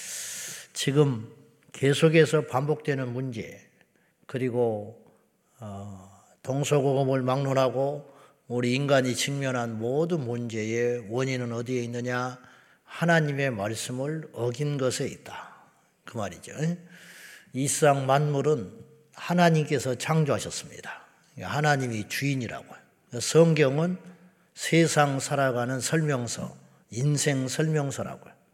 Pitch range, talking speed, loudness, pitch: 120-150 Hz, 235 characters per minute, -26 LUFS, 135 Hz